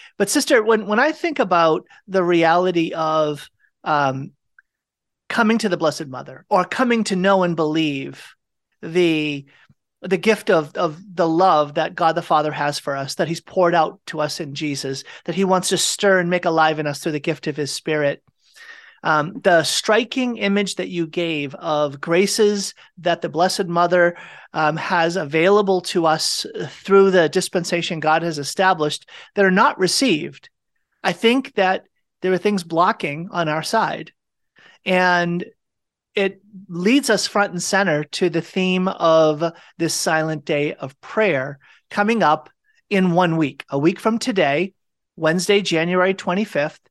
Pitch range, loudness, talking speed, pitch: 155-195 Hz, -19 LUFS, 160 wpm, 175 Hz